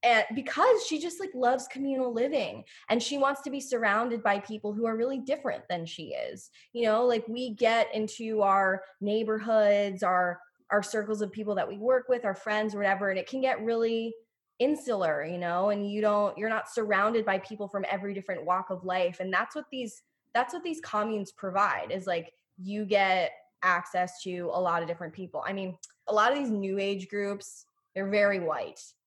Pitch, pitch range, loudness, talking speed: 210 Hz, 195-245 Hz, -29 LUFS, 200 wpm